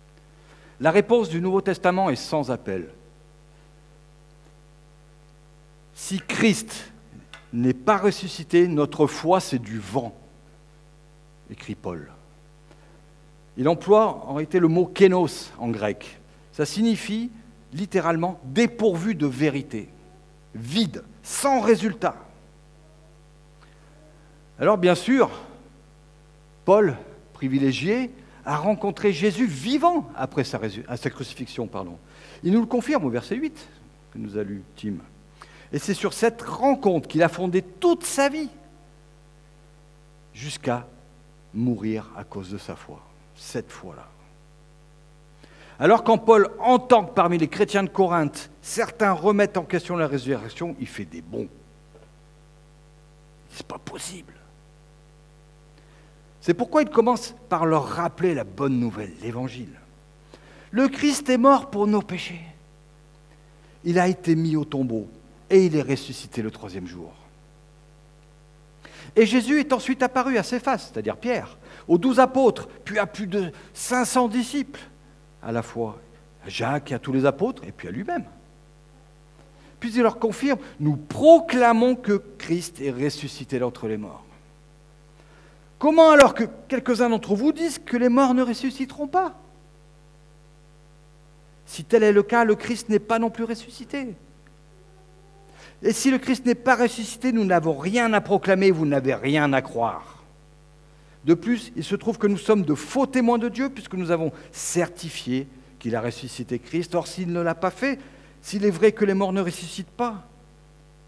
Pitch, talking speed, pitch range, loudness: 150 Hz, 145 wpm, 145-210 Hz, -23 LUFS